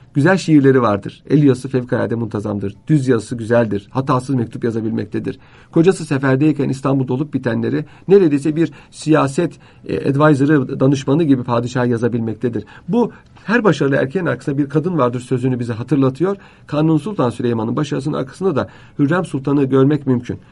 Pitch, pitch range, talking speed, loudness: 135 Hz, 120-150 Hz, 140 wpm, -17 LUFS